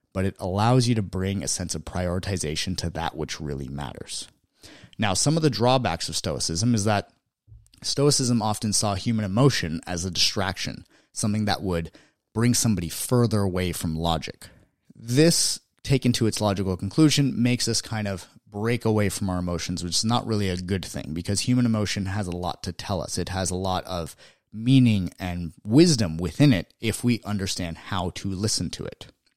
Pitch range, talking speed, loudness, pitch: 90-115 Hz, 185 wpm, -24 LUFS, 100 Hz